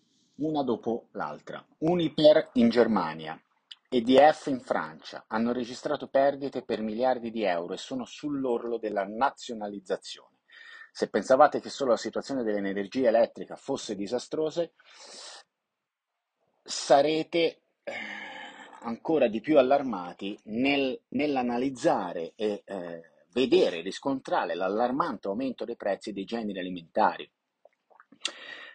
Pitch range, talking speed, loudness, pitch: 105-140 Hz, 105 wpm, -28 LUFS, 120 Hz